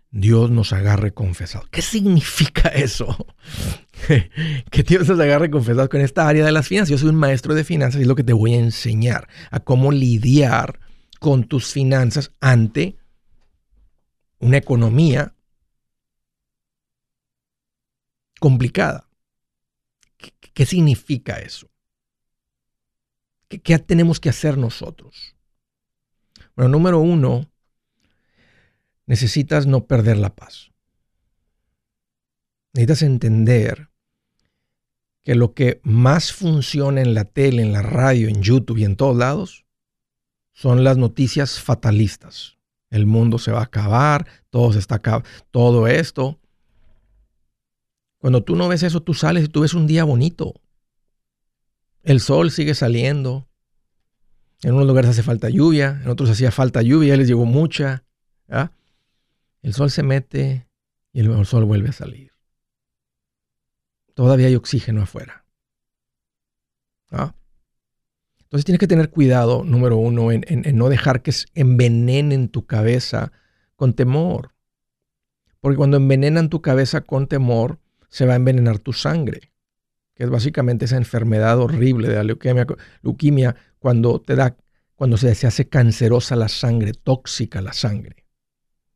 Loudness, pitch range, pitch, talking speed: -17 LUFS, 115-145 Hz, 130 Hz, 135 wpm